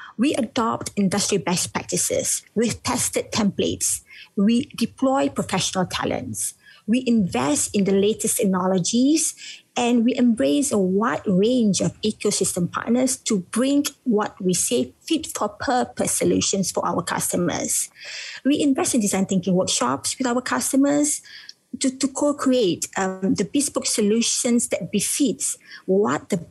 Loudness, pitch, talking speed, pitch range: -21 LUFS, 230 Hz, 135 wpm, 195-265 Hz